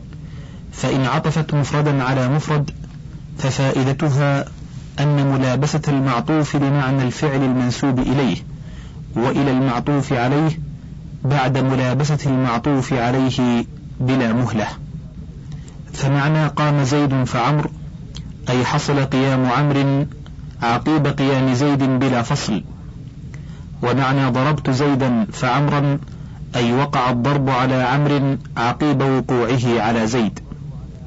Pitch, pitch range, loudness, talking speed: 140 Hz, 130-145 Hz, -18 LUFS, 95 wpm